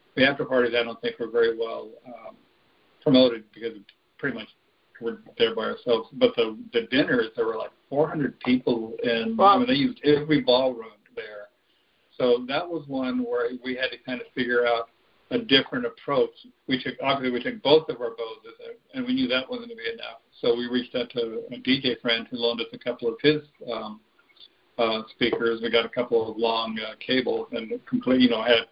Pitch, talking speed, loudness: 130 Hz, 205 wpm, -25 LUFS